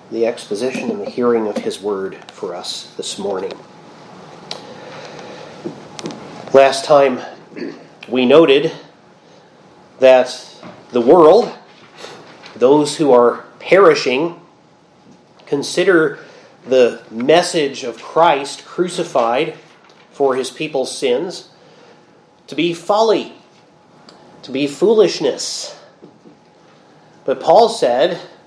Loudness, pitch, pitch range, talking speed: -15 LUFS, 145 Hz, 130-220 Hz, 90 wpm